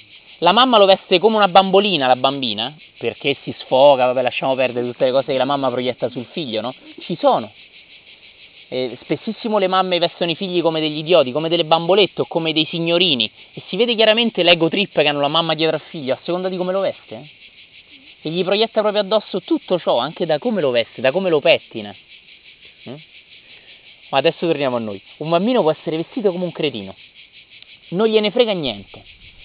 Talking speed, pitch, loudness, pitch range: 200 wpm, 165 Hz, -17 LUFS, 135-195 Hz